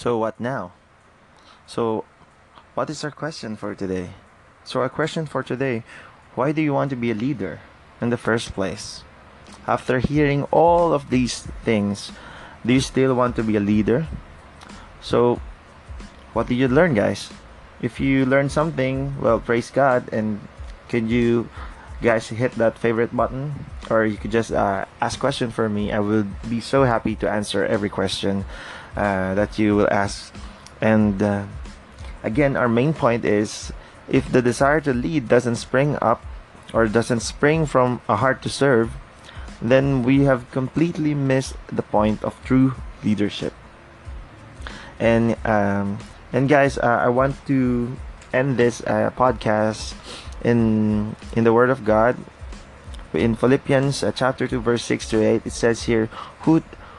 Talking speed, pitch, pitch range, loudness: 160 wpm, 115 Hz, 105-130 Hz, -21 LUFS